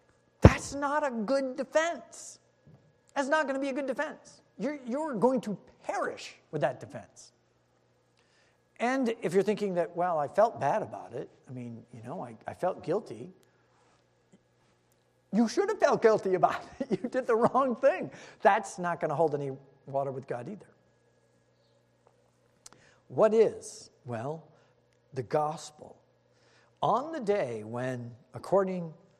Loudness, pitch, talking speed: -30 LUFS, 195 Hz, 155 wpm